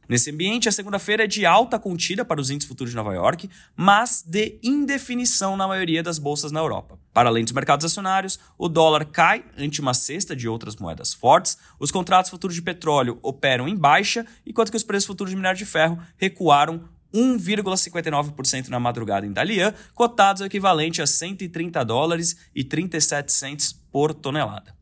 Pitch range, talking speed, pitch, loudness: 145-200 Hz, 175 wpm, 170 Hz, -20 LUFS